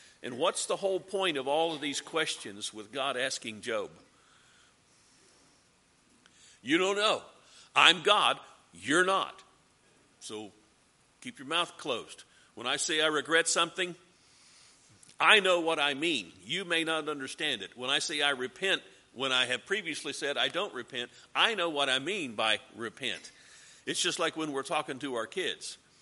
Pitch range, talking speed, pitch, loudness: 135-180 Hz, 165 wpm, 160 Hz, -29 LUFS